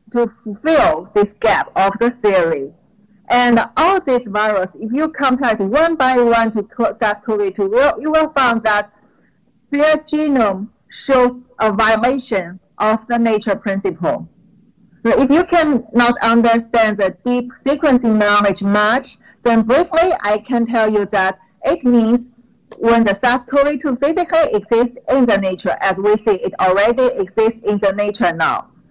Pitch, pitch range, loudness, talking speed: 230 Hz, 205-260 Hz, -15 LUFS, 150 wpm